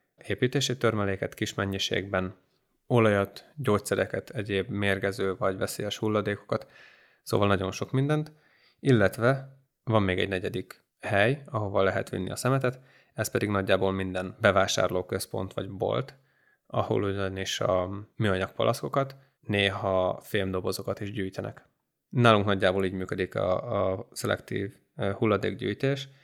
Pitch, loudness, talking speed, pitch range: 100 Hz, -28 LUFS, 110 wpm, 95-120 Hz